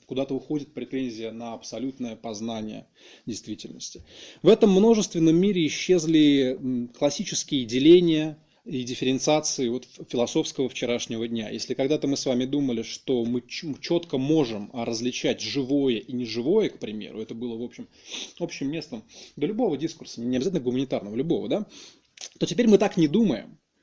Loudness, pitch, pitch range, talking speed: -25 LUFS, 130 Hz, 120-155 Hz, 150 wpm